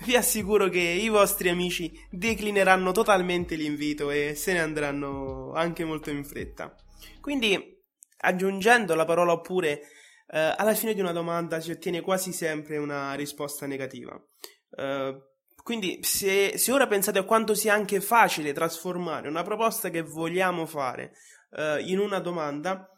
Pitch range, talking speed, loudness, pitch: 150-200 Hz, 145 wpm, -26 LUFS, 175 Hz